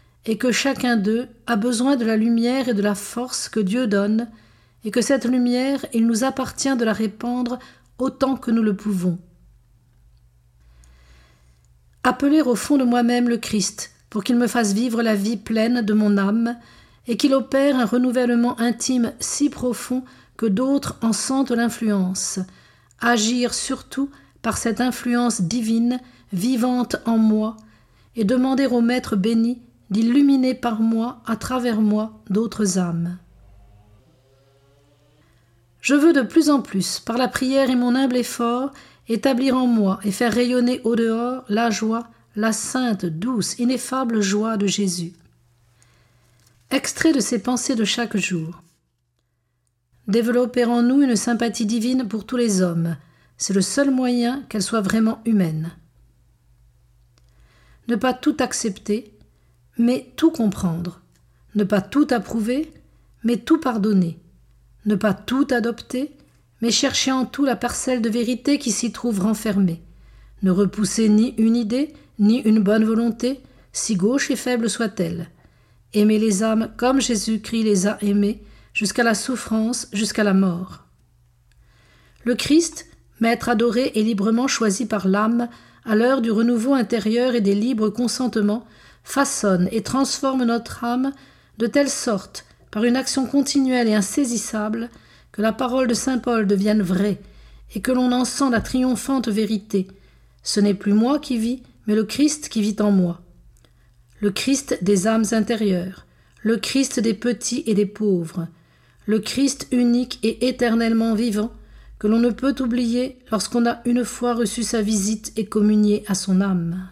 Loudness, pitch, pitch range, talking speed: -21 LUFS, 225 Hz, 200-245 Hz, 150 wpm